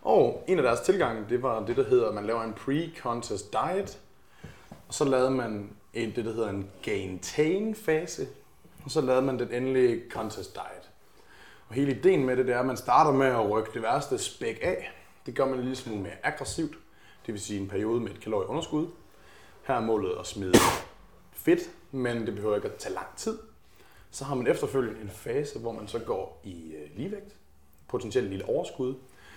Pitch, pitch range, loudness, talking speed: 125 Hz, 105-150 Hz, -29 LUFS, 200 wpm